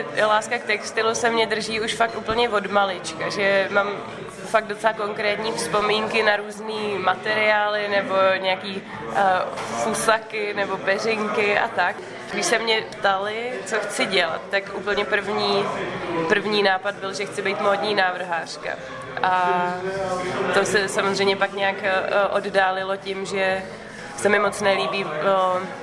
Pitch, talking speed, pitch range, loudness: 200 Hz, 140 wpm, 195-215 Hz, -22 LUFS